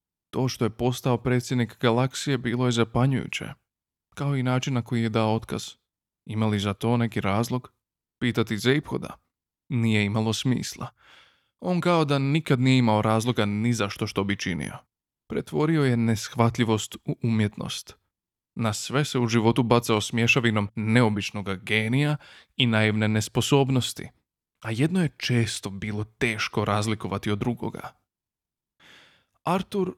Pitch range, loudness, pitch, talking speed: 110-130 Hz, -25 LUFS, 115 Hz, 135 wpm